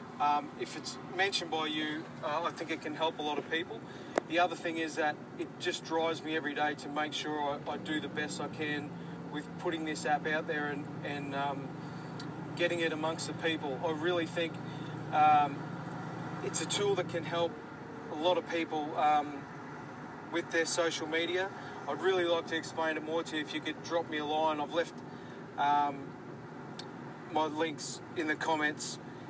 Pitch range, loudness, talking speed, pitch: 150-165 Hz, -34 LUFS, 195 wpm, 155 Hz